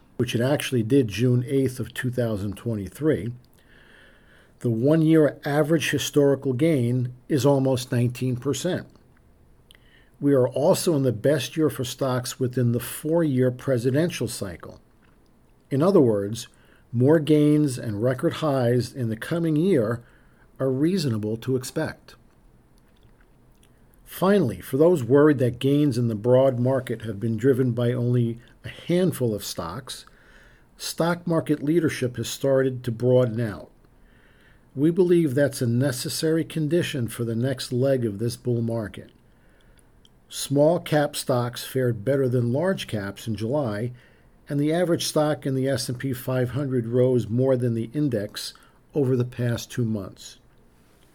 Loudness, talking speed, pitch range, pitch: -23 LUFS, 135 wpm, 120-145 Hz, 130 Hz